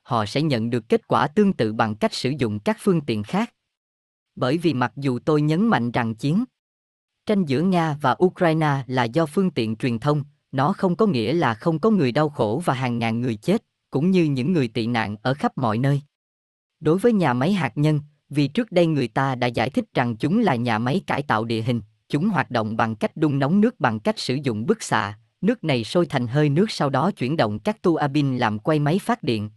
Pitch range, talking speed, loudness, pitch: 120-175 Hz, 235 wpm, -22 LUFS, 140 Hz